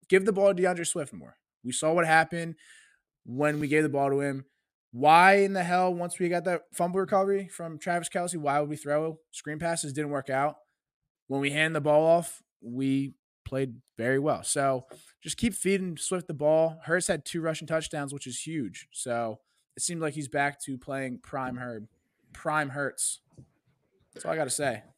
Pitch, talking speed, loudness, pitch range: 155 Hz, 195 wpm, -28 LUFS, 140-175 Hz